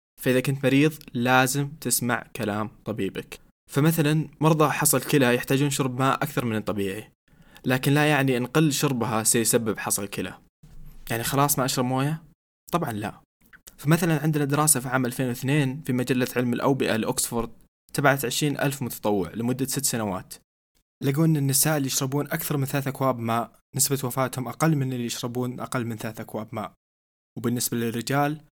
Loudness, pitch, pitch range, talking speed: -24 LUFS, 130 Hz, 120-145 Hz, 155 wpm